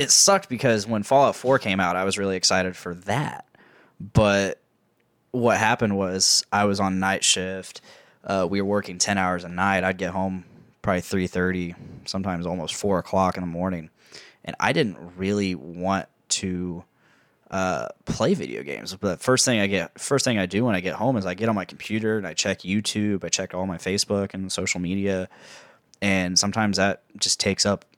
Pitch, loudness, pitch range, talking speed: 95 Hz, -23 LUFS, 90-105 Hz, 195 wpm